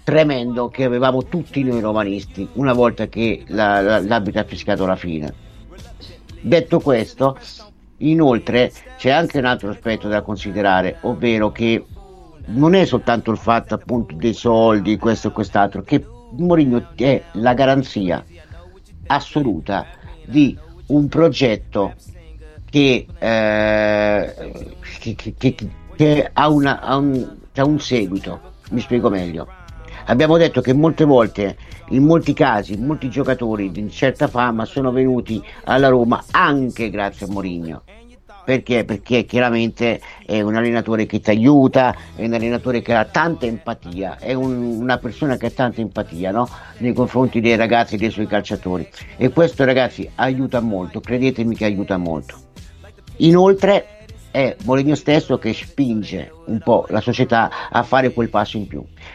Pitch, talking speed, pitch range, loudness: 115 Hz, 145 wpm, 100-130 Hz, -18 LUFS